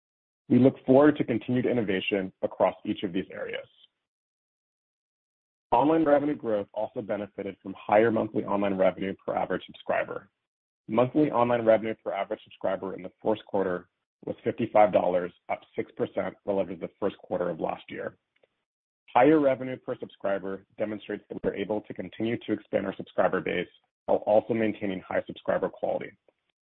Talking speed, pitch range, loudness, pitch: 150 wpm, 100-125 Hz, -28 LUFS, 110 Hz